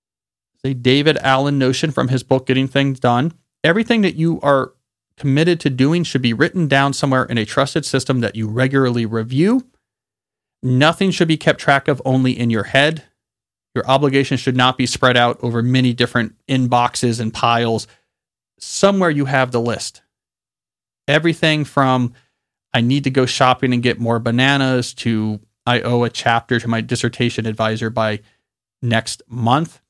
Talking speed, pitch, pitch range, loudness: 165 wpm, 130 Hz, 120-140 Hz, -17 LUFS